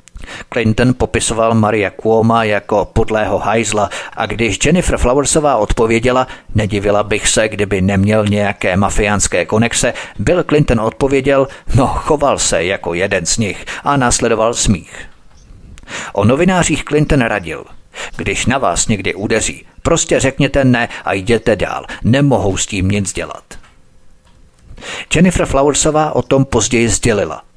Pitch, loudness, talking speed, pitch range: 115 Hz, -14 LUFS, 130 wpm, 100-135 Hz